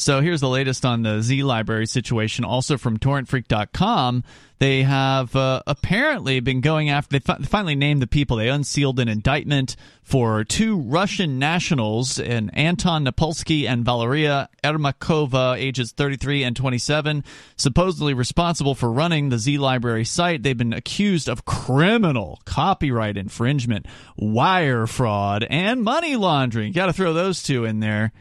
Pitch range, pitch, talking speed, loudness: 120-155 Hz, 135 Hz, 150 wpm, -21 LUFS